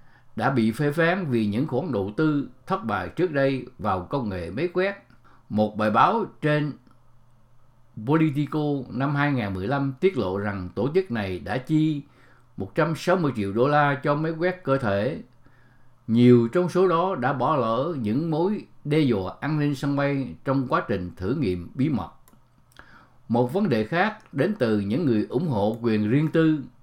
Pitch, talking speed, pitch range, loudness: 130 Hz, 170 wpm, 115-150 Hz, -24 LUFS